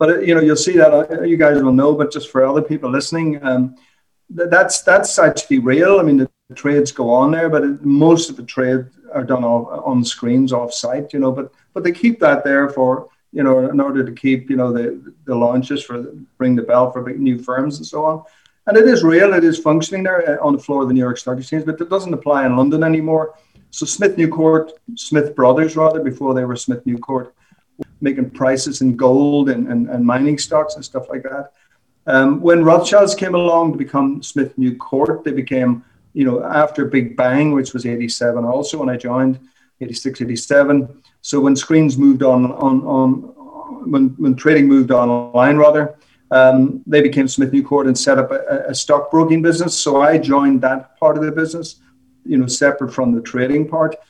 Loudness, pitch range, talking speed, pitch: -15 LUFS, 130-155 Hz, 215 wpm, 140 Hz